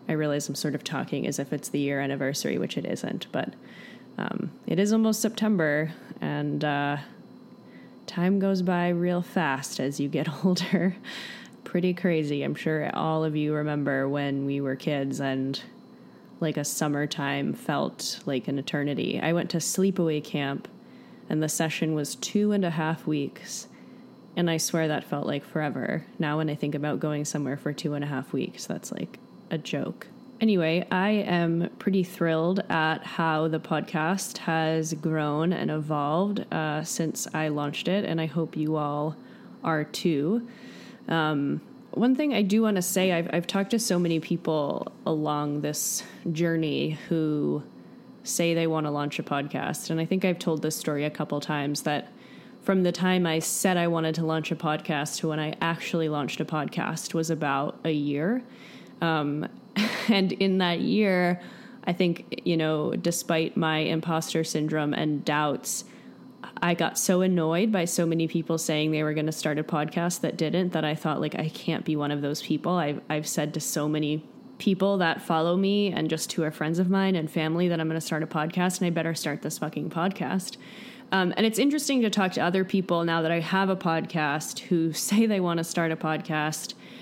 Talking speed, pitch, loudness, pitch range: 190 wpm, 165 Hz, -27 LUFS, 150-185 Hz